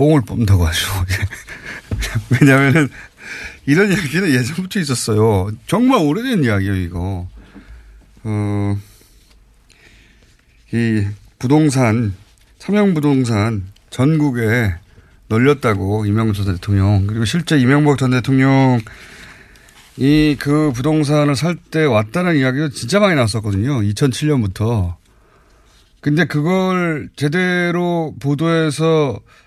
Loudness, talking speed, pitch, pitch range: -16 LUFS, 230 characters per minute, 125 Hz, 100-150 Hz